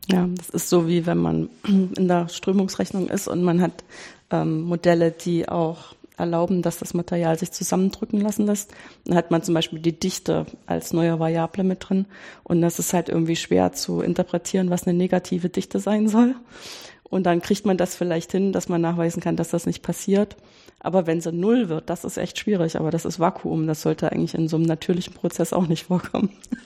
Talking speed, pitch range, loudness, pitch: 205 wpm, 165-190 Hz, -23 LUFS, 175 Hz